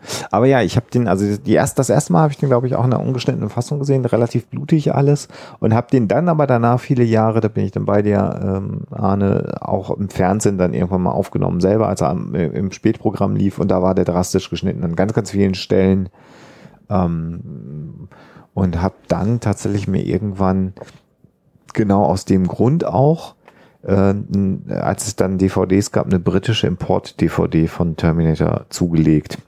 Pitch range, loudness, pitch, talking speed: 95-125 Hz, -17 LUFS, 100 Hz, 185 wpm